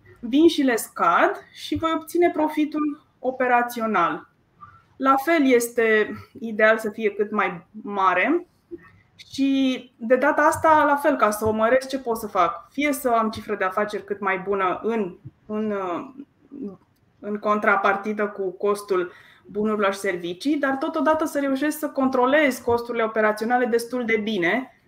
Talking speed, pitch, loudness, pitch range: 145 wpm, 235 Hz, -22 LUFS, 210-280 Hz